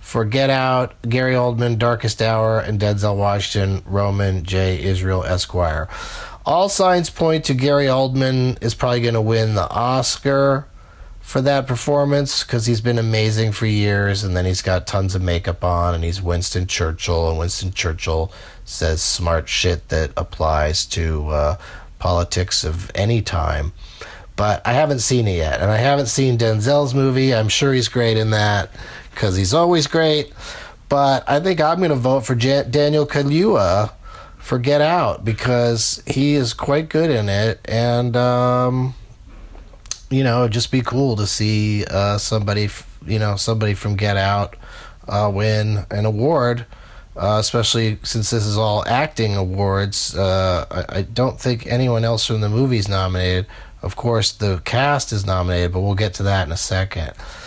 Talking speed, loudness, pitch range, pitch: 170 wpm, -18 LUFS, 95-125 Hz, 110 Hz